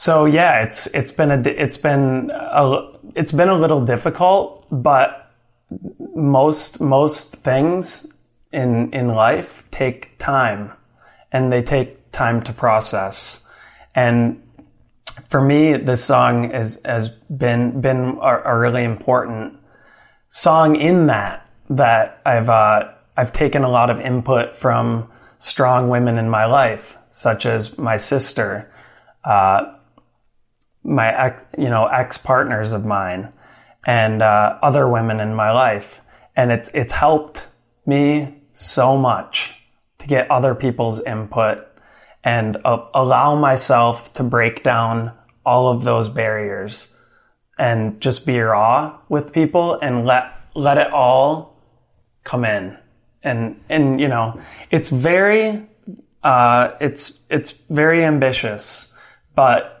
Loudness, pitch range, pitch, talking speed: -17 LUFS, 115-145 Hz, 125 Hz, 125 wpm